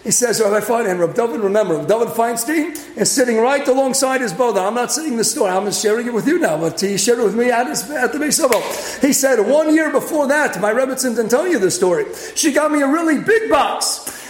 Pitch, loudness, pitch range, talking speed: 255 Hz, -16 LUFS, 220-300 Hz, 245 wpm